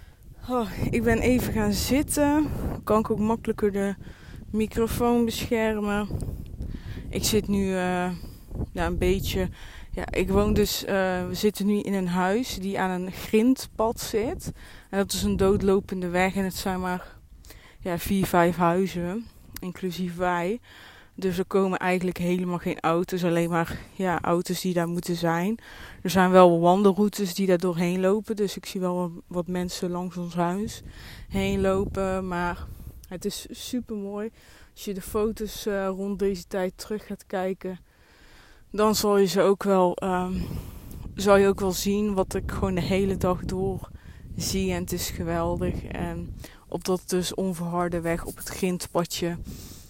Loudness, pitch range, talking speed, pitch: -26 LUFS, 180-205 Hz, 165 wpm, 190 Hz